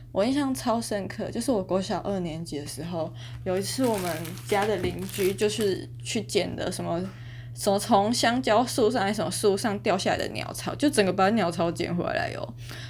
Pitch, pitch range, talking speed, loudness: 195 Hz, 160-215 Hz, 295 characters per minute, -27 LUFS